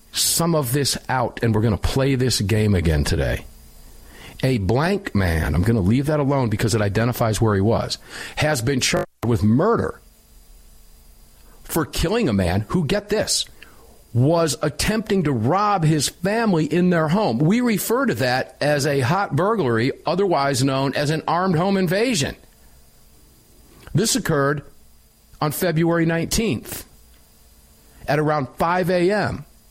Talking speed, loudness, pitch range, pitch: 145 wpm, -20 LUFS, 110-170 Hz, 140 Hz